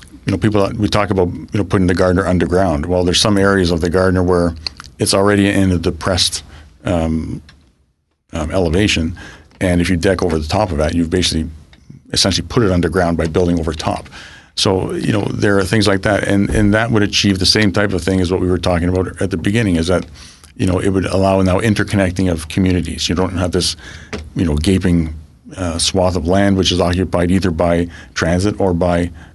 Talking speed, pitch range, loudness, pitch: 215 wpm, 85-95 Hz, -15 LUFS, 90 Hz